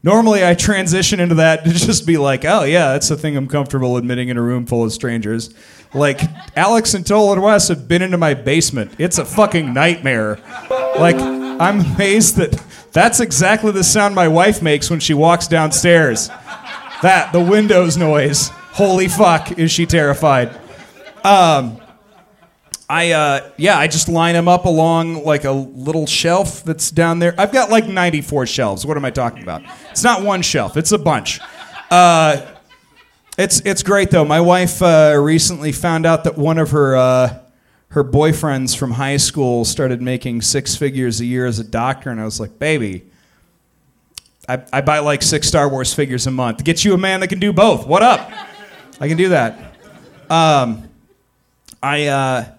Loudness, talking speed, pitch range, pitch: -14 LUFS, 180 wpm, 135-175 Hz, 155 Hz